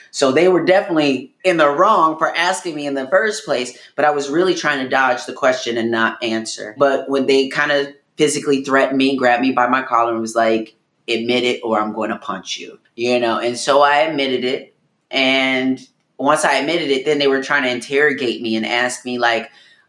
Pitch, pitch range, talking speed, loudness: 135 Hz, 120-145 Hz, 220 wpm, -17 LUFS